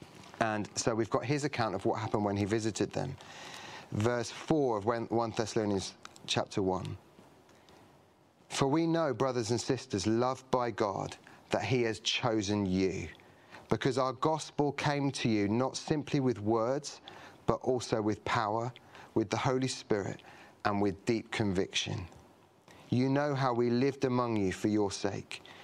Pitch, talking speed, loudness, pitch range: 120 Hz, 155 wpm, -32 LUFS, 110-130 Hz